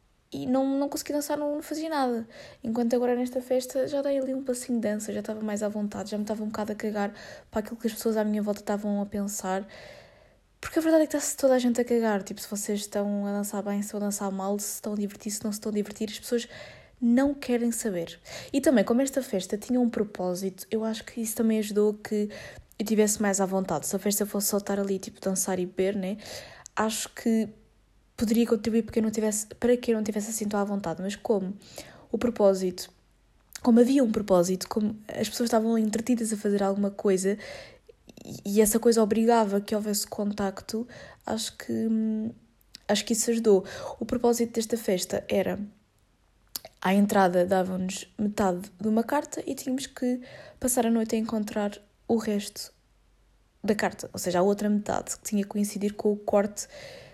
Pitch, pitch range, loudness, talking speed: 215 Hz, 200-235 Hz, -27 LUFS, 205 wpm